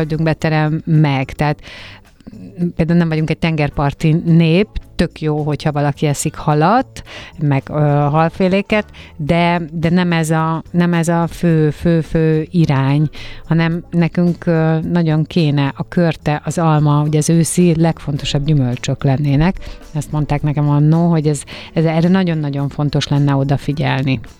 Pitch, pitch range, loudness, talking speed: 155 Hz, 145-165 Hz, -15 LUFS, 145 wpm